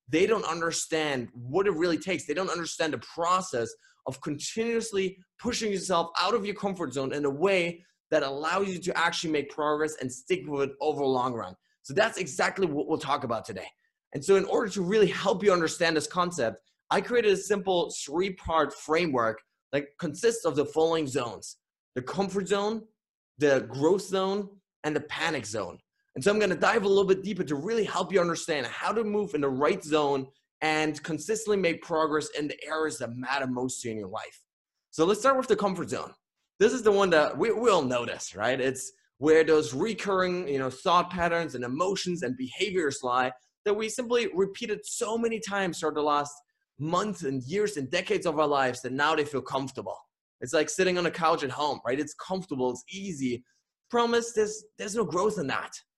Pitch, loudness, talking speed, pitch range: 170 Hz, -28 LUFS, 205 wpm, 145-200 Hz